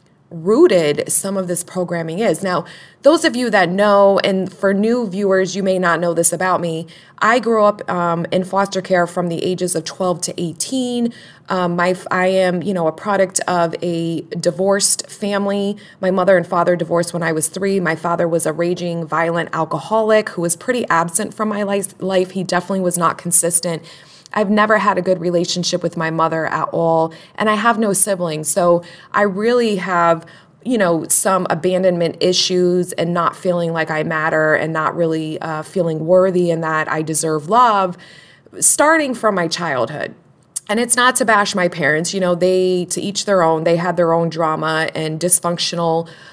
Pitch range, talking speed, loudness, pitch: 165-195 Hz, 185 wpm, -16 LUFS, 180 Hz